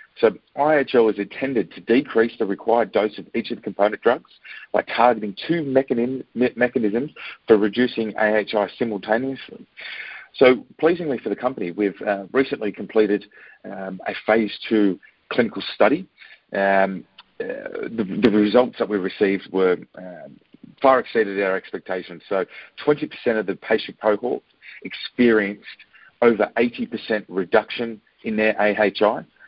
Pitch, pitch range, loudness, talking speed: 110 Hz, 100-125 Hz, -21 LUFS, 135 wpm